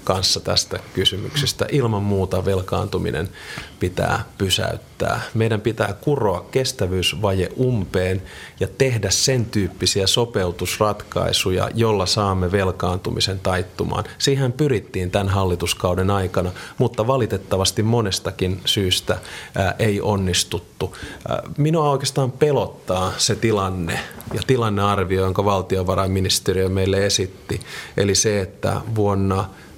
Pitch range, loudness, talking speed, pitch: 95-115 Hz, -20 LUFS, 95 wpm, 100 Hz